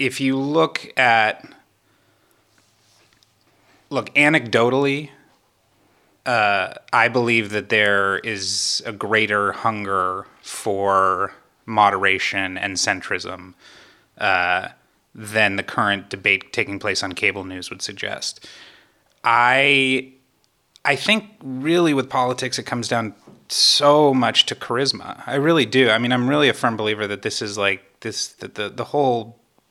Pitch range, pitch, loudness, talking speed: 100-130 Hz, 115 Hz, -19 LUFS, 125 wpm